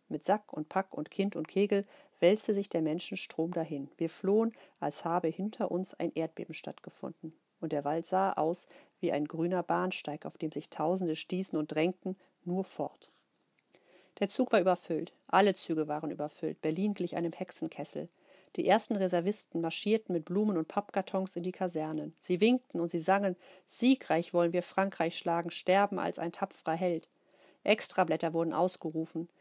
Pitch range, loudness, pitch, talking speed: 160-195 Hz, -33 LUFS, 180 Hz, 165 wpm